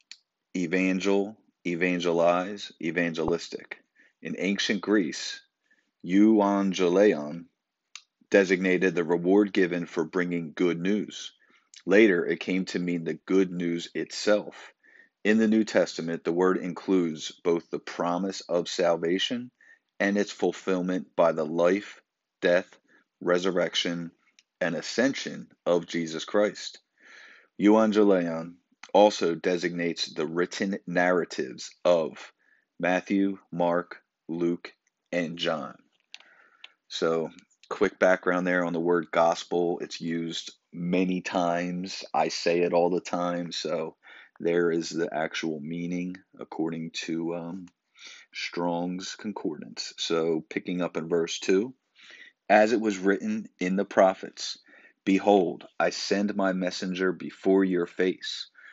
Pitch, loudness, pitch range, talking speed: 90 Hz, -27 LUFS, 85-95 Hz, 115 wpm